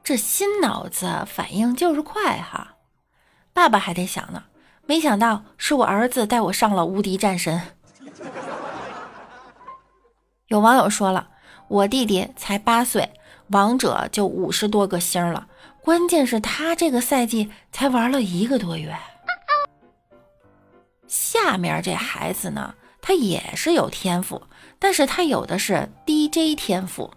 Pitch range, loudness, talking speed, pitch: 200-305 Hz, -21 LUFS, 195 characters per minute, 235 Hz